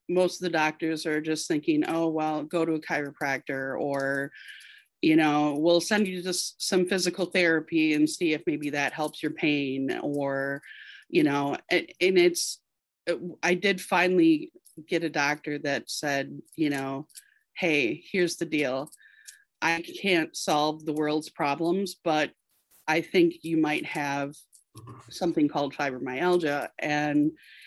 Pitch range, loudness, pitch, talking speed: 145-180 Hz, -27 LUFS, 155 Hz, 145 wpm